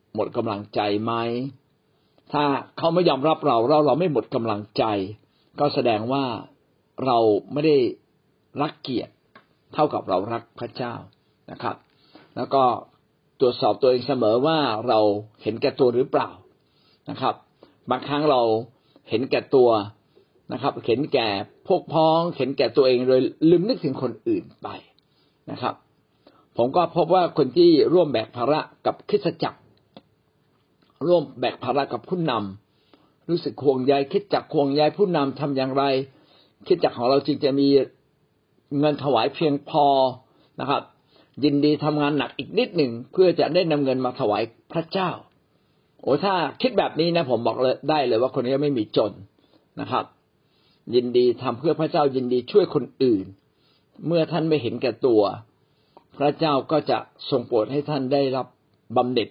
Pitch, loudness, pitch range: 140 Hz, -22 LUFS, 125-155 Hz